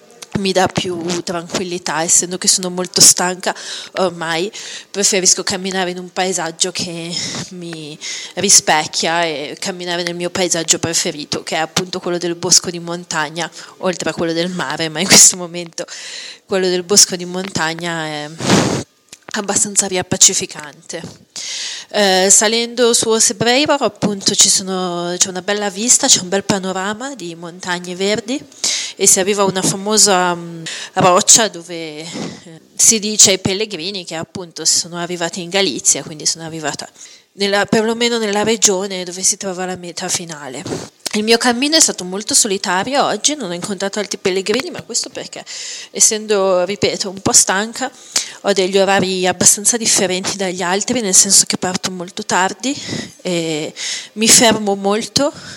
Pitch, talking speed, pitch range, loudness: 190 Hz, 150 wpm, 175-205 Hz, -14 LUFS